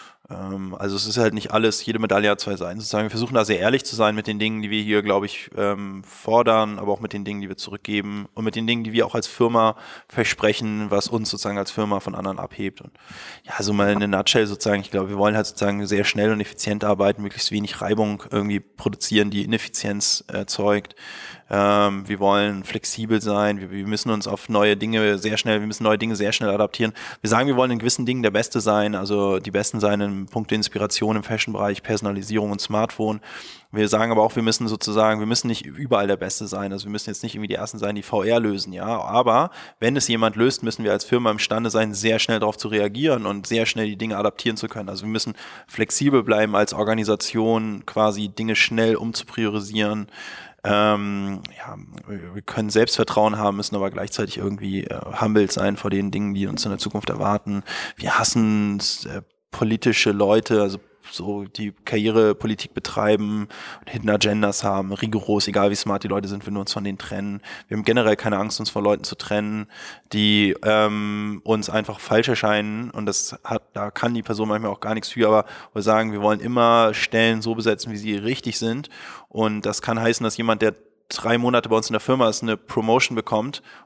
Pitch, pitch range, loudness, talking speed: 105 Hz, 100-110 Hz, -22 LUFS, 210 wpm